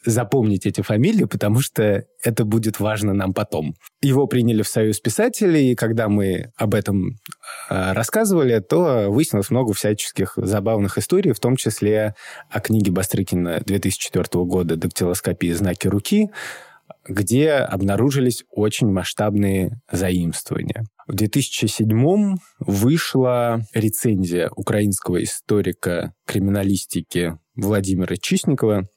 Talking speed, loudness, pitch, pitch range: 110 wpm, -20 LUFS, 105 Hz, 100-120 Hz